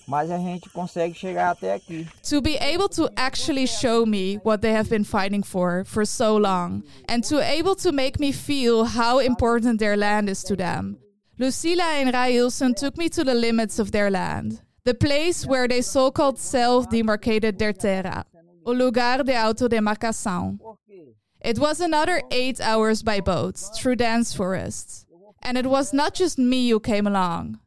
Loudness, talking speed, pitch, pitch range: -22 LUFS, 155 wpm, 225 Hz, 195-260 Hz